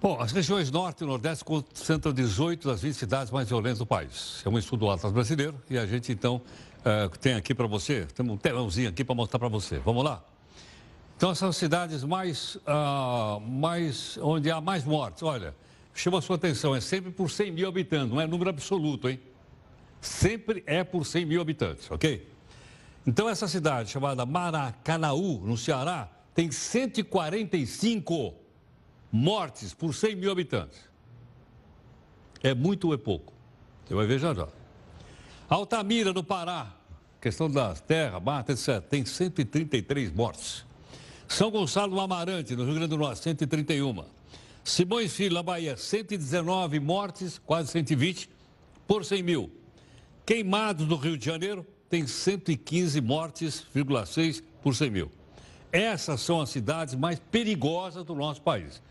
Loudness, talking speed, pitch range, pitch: -29 LUFS, 155 wpm, 130-180 Hz, 155 Hz